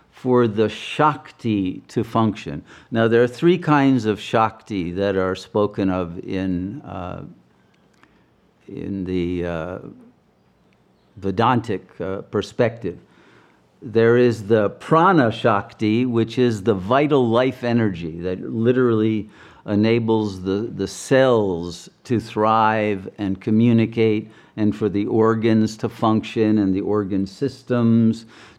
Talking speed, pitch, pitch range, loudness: 115 wpm, 110 Hz, 100-120 Hz, -20 LUFS